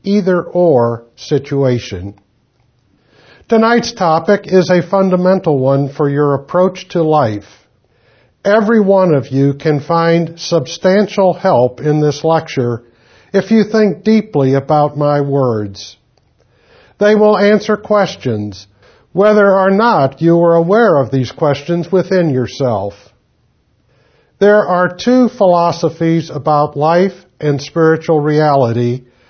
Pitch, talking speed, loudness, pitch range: 160 Hz, 115 wpm, -12 LUFS, 130-185 Hz